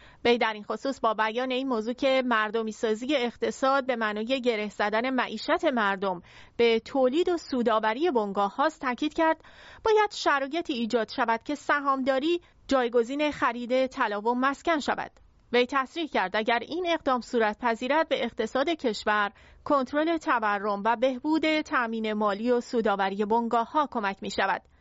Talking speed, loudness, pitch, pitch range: 150 wpm, -27 LUFS, 245 Hz, 225-285 Hz